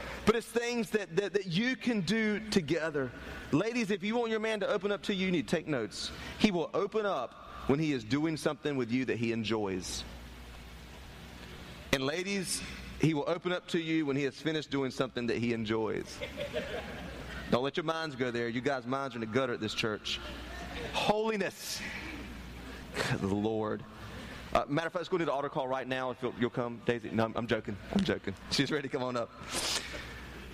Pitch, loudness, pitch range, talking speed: 135 Hz, -33 LUFS, 110-180 Hz, 205 wpm